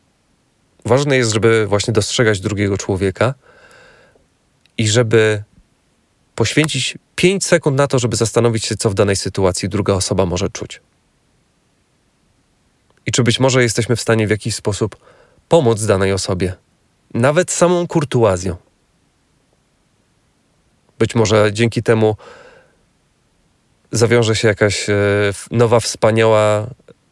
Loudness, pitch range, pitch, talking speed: -16 LUFS, 105-120 Hz, 110 Hz, 115 wpm